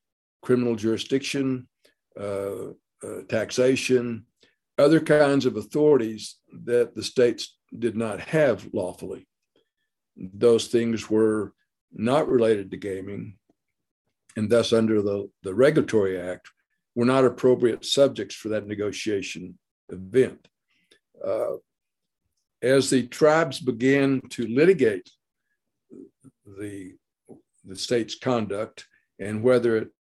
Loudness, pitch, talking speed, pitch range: -23 LUFS, 120 Hz, 105 wpm, 105-130 Hz